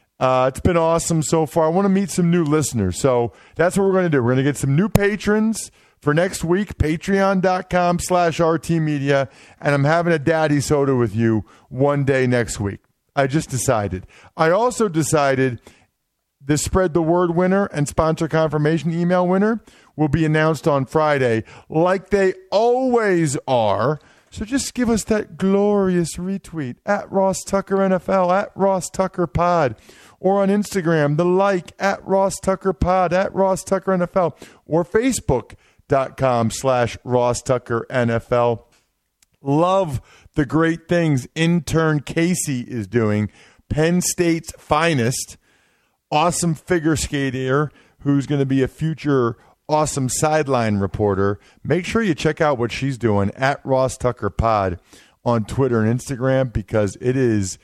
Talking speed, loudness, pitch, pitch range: 155 wpm, -19 LUFS, 155 Hz, 130-180 Hz